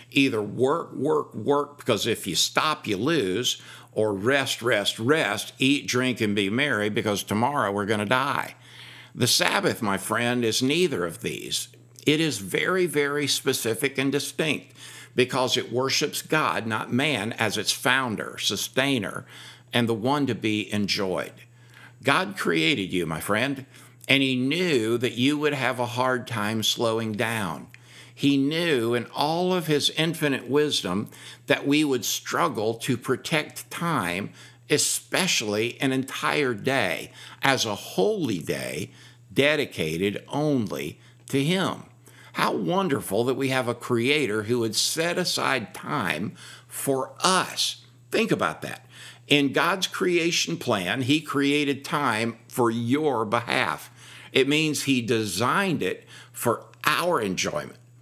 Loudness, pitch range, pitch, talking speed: -24 LUFS, 115-145 Hz, 125 Hz, 140 wpm